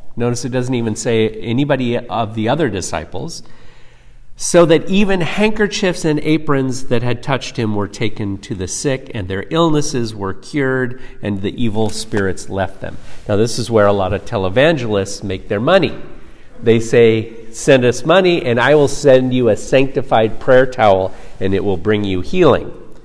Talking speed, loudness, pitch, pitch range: 175 wpm, -16 LUFS, 120 Hz, 105-140 Hz